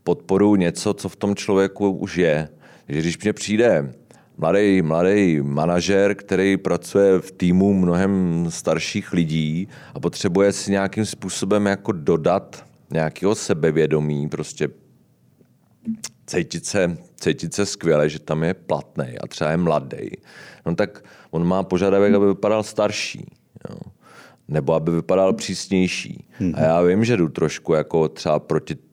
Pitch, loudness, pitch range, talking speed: 95 Hz, -20 LUFS, 80-100 Hz, 140 wpm